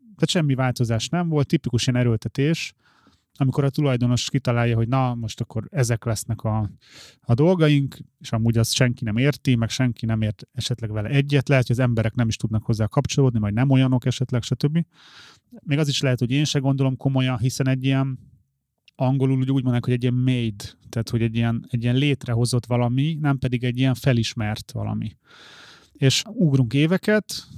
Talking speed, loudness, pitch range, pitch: 185 wpm, -22 LUFS, 115-140 Hz, 130 Hz